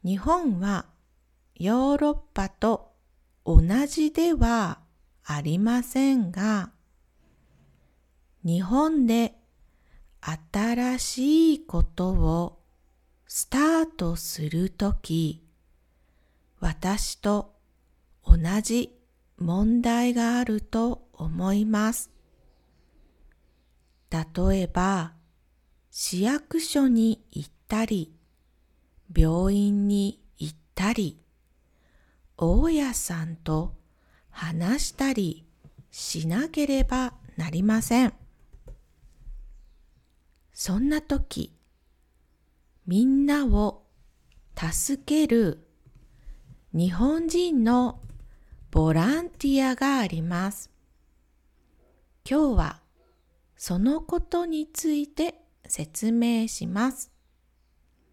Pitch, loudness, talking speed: 185 Hz, -26 LUFS, 135 characters per minute